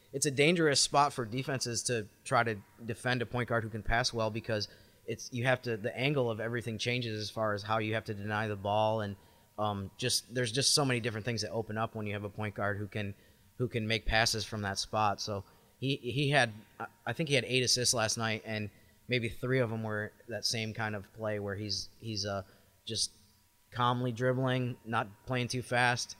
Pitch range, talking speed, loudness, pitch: 105-125 Hz, 225 wpm, -32 LUFS, 110 Hz